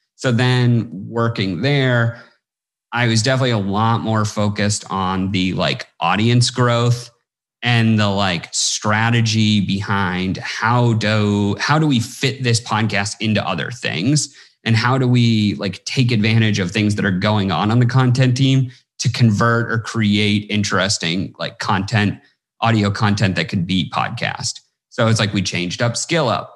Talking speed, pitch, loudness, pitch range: 160 wpm, 110 Hz, -17 LUFS, 100-120 Hz